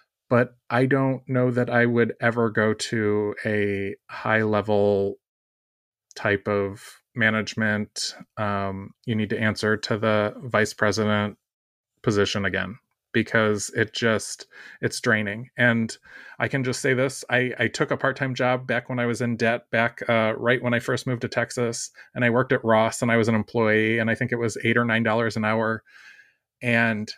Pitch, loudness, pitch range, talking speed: 115 Hz, -24 LUFS, 105-120 Hz, 180 wpm